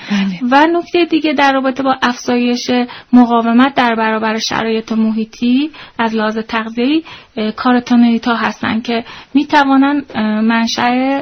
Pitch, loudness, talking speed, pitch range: 245 Hz, -13 LUFS, 105 wpm, 225-270 Hz